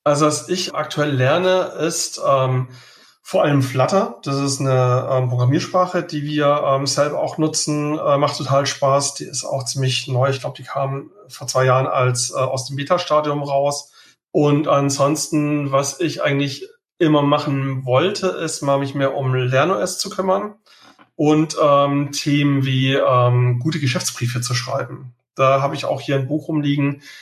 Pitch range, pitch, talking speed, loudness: 135-155 Hz, 140 Hz, 170 wpm, -19 LUFS